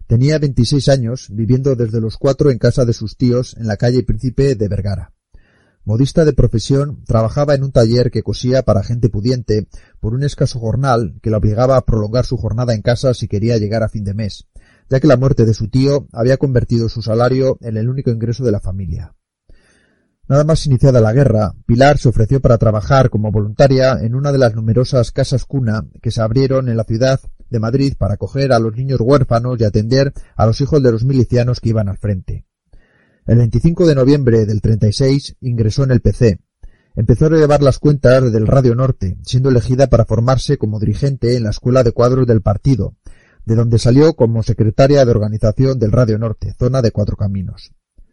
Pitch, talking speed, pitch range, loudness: 120 Hz, 195 wpm, 110-130 Hz, -14 LUFS